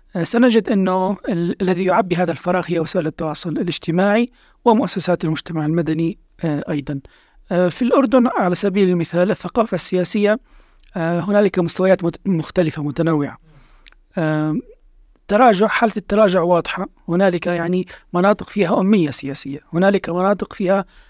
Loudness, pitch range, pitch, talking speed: -18 LUFS, 165-205 Hz, 180 Hz, 130 wpm